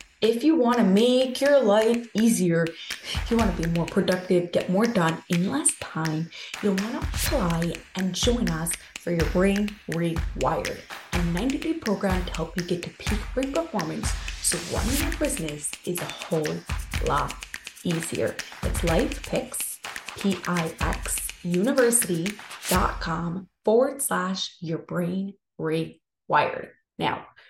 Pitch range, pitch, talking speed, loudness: 170-230 Hz, 190 Hz, 140 wpm, -25 LUFS